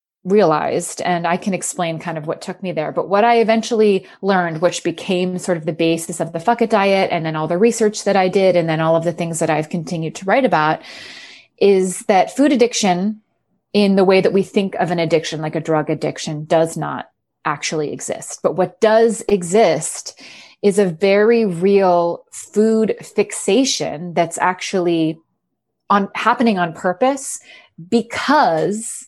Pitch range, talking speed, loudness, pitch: 170-210 Hz, 175 wpm, -17 LUFS, 185 Hz